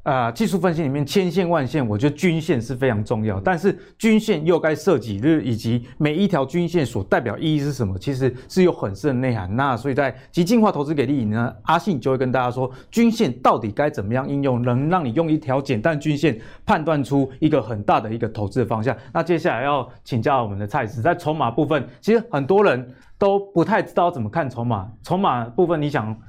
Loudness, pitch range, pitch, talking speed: -21 LUFS, 125-170 Hz, 145 Hz, 340 characters per minute